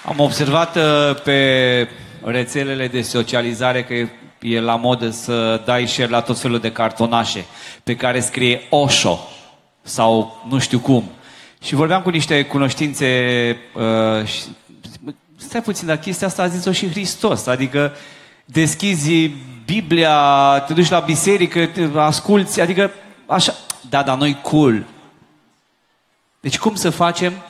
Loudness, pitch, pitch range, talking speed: -17 LUFS, 140 Hz, 120-170 Hz, 140 wpm